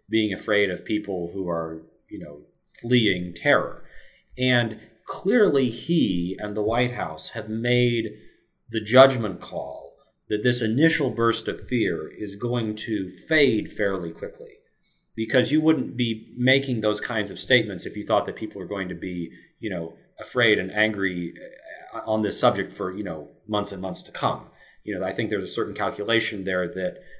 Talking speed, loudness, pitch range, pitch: 170 wpm, -24 LUFS, 95-120 Hz, 110 Hz